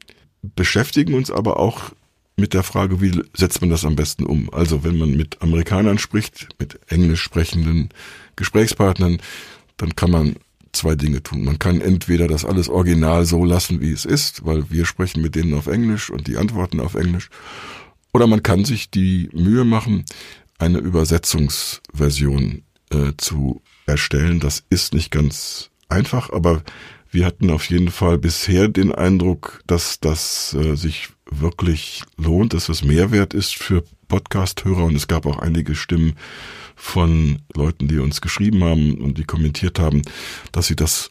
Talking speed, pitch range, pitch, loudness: 160 wpm, 75-95 Hz, 85 Hz, -19 LUFS